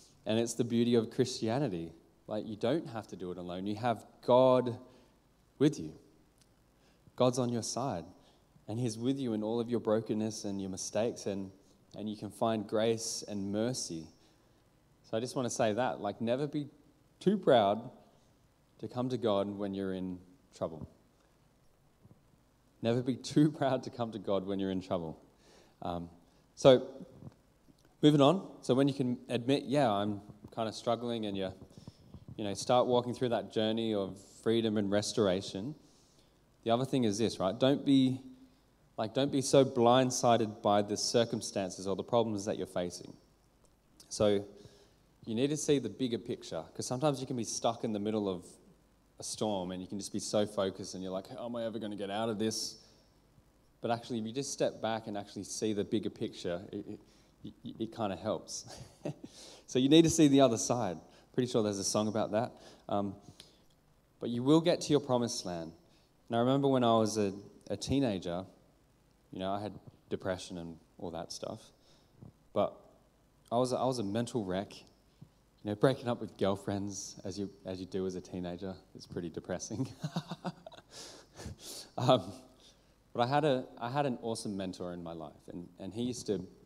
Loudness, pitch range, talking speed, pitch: -33 LUFS, 100-125 Hz, 185 wpm, 110 Hz